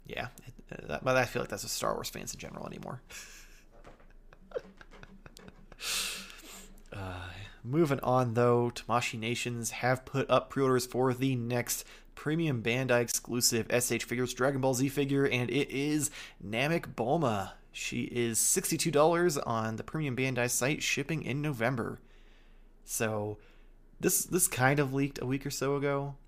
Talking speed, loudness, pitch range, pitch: 150 wpm, -31 LUFS, 120-140 Hz, 130 Hz